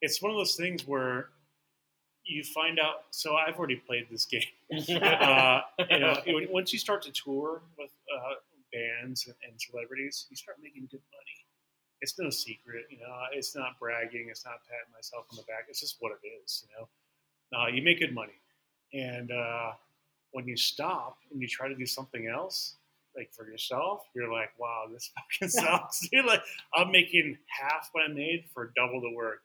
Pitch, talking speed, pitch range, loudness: 130 Hz, 190 wpm, 115-160 Hz, -29 LUFS